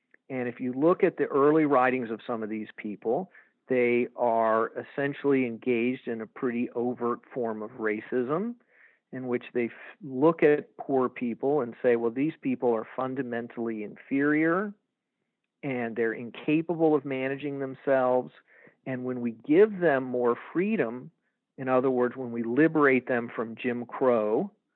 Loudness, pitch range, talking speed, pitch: -28 LUFS, 120-140 Hz, 155 wpm, 125 Hz